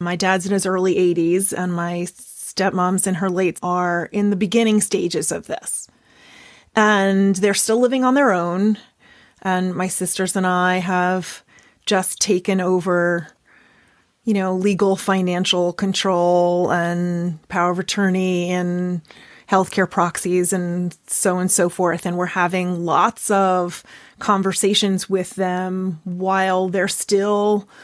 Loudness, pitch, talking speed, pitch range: -19 LUFS, 185 Hz, 140 wpm, 180-195 Hz